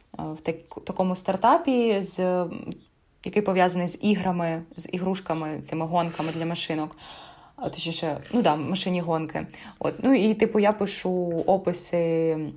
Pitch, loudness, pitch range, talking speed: 180 Hz, -25 LUFS, 165-195 Hz, 130 wpm